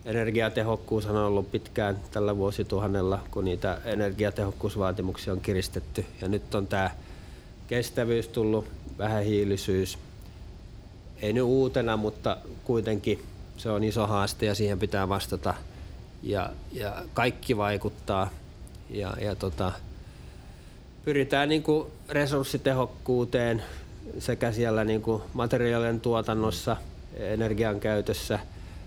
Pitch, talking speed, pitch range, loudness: 105 Hz, 100 wpm, 95-115 Hz, -29 LUFS